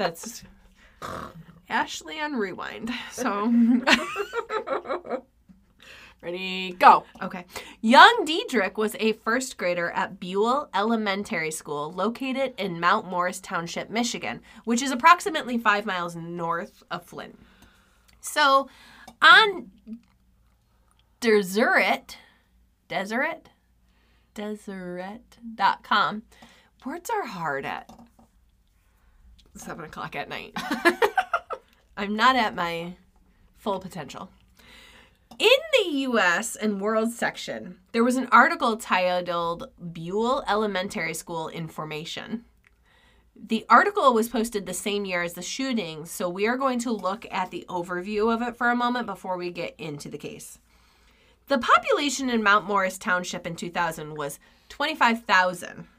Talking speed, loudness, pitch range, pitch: 115 wpm, -24 LUFS, 180-245 Hz, 210 Hz